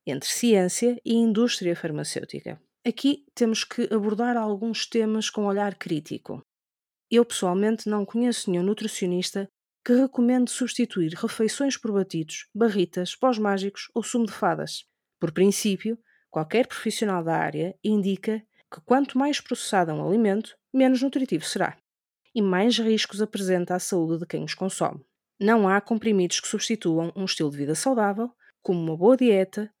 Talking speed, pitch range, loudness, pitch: 145 wpm, 185-235 Hz, -25 LUFS, 215 Hz